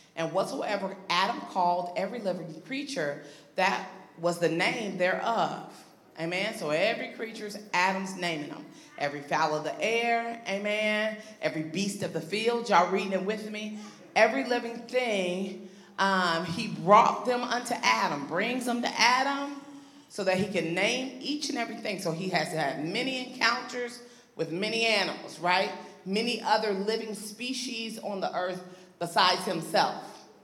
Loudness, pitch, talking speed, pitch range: -29 LUFS, 205 Hz, 150 wpm, 180-235 Hz